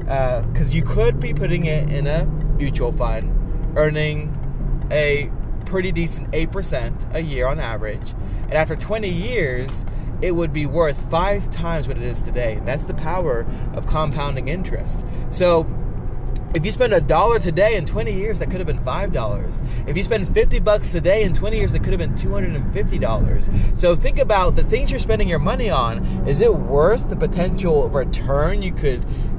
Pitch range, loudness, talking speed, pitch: 130-165 Hz, -21 LUFS, 190 wpm, 150 Hz